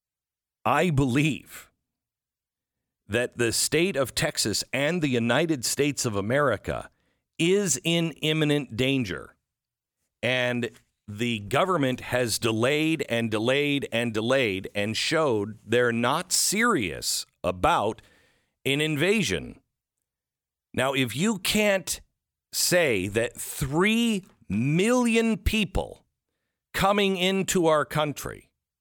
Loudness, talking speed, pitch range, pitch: -25 LUFS, 100 wpm, 120-170 Hz, 140 Hz